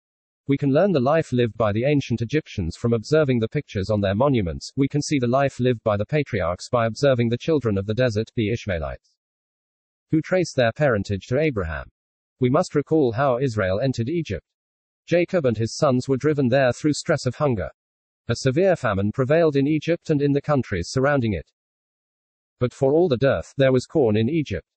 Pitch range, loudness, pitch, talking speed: 110-145 Hz, -22 LUFS, 125 Hz, 195 wpm